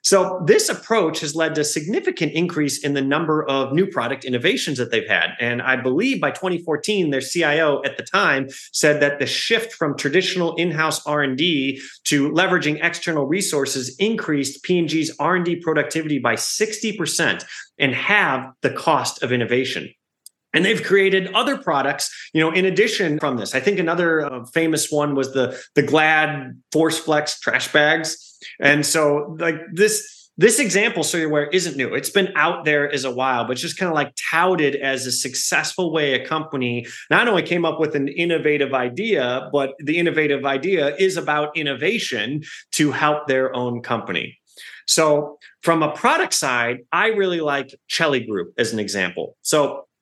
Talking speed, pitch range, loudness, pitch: 170 wpm, 140-170 Hz, -20 LUFS, 150 Hz